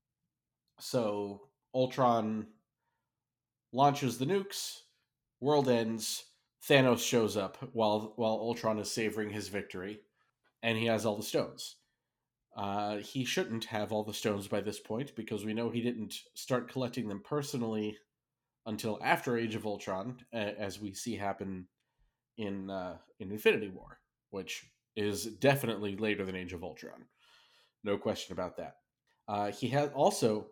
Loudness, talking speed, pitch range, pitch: -34 LUFS, 145 wpm, 105-130 Hz, 110 Hz